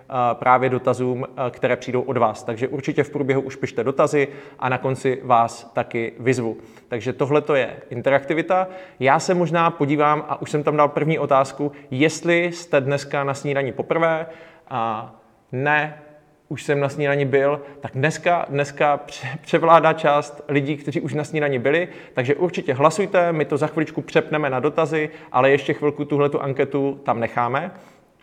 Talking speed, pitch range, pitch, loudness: 160 wpm, 130-155 Hz, 145 Hz, -21 LUFS